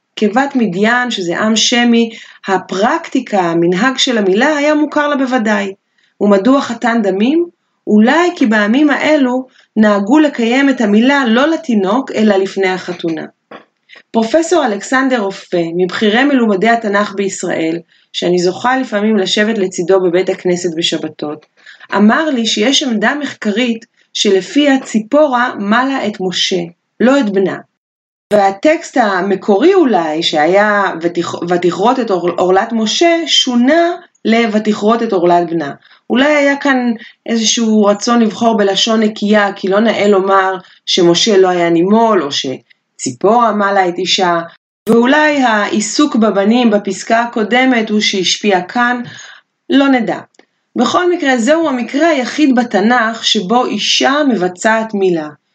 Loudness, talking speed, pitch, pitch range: -12 LUFS, 120 wpm, 220 Hz, 195-255 Hz